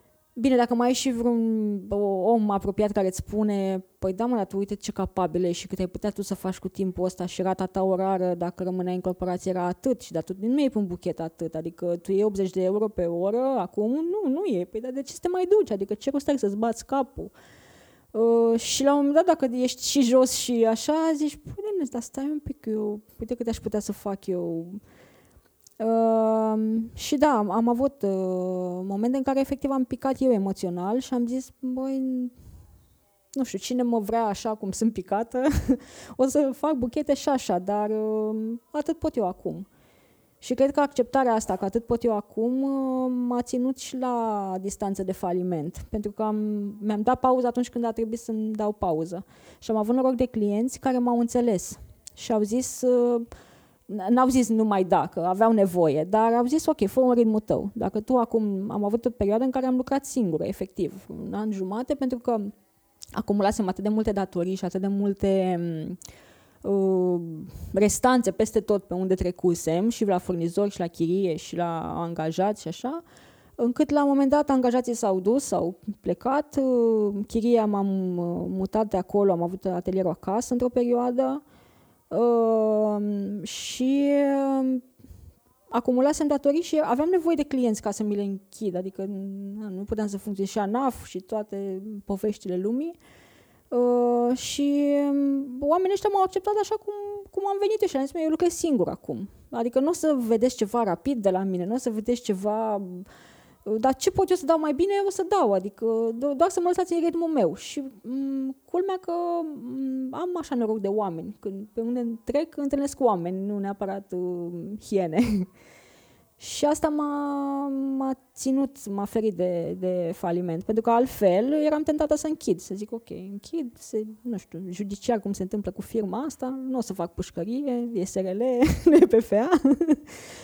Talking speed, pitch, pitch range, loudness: 185 wpm, 225 Hz, 195-265 Hz, -26 LUFS